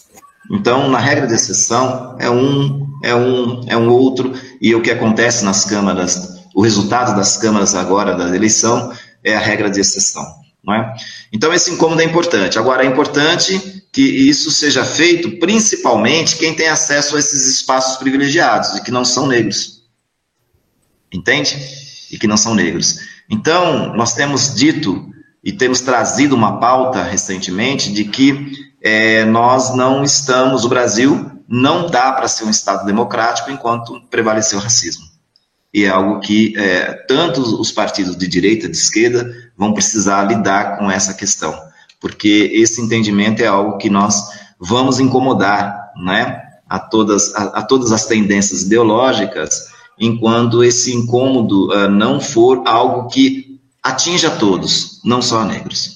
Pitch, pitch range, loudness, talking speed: 120 Hz, 105-140 Hz, -13 LUFS, 155 wpm